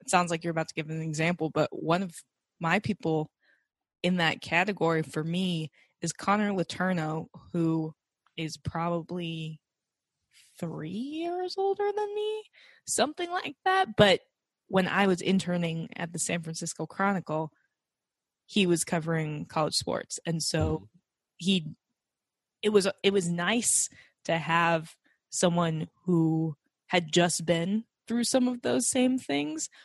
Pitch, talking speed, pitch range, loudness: 175 Hz, 140 wpm, 160-200 Hz, -29 LUFS